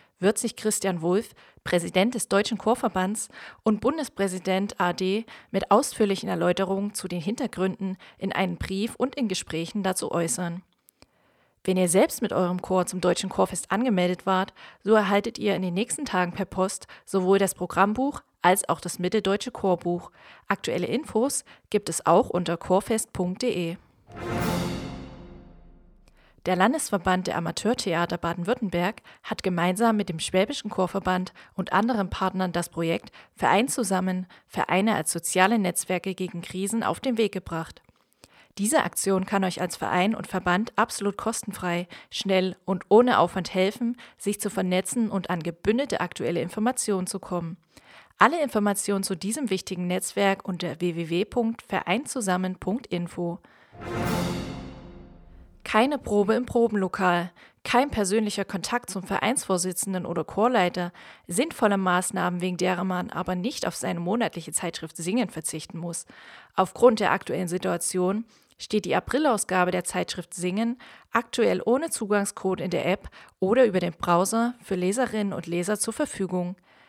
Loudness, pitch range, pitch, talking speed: -26 LUFS, 180-215 Hz, 190 Hz, 135 wpm